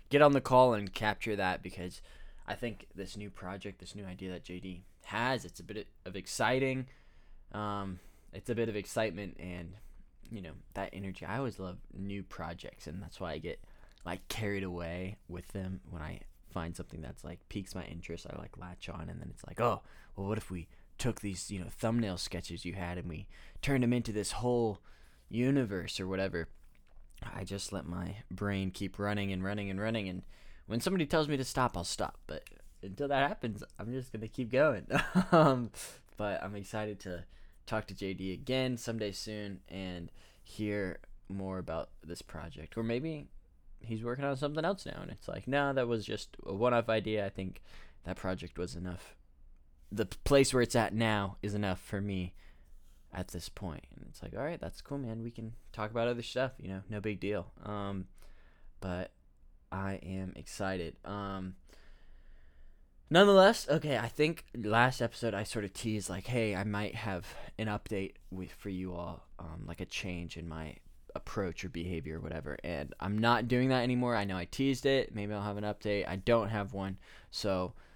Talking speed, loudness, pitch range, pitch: 195 wpm, -35 LUFS, 90-115 Hz, 95 Hz